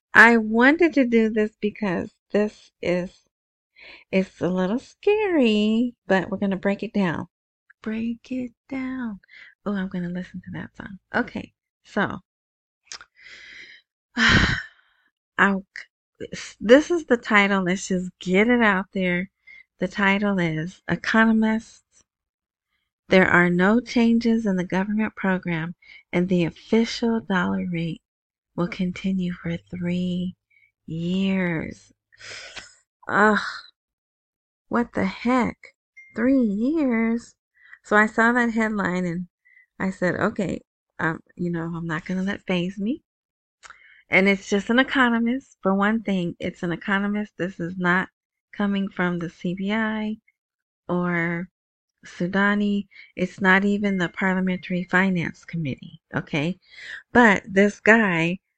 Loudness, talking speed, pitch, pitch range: -22 LUFS, 125 wpm, 195 Hz, 180-230 Hz